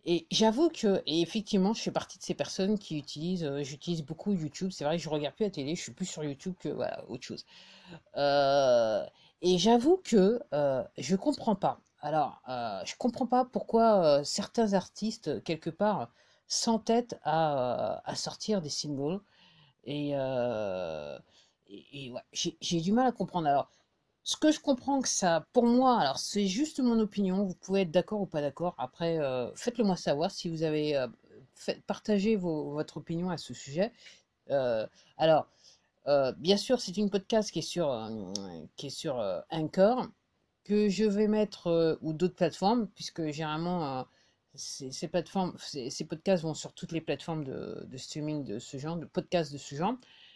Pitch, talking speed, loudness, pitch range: 180 Hz, 185 wpm, -31 LUFS, 150-210 Hz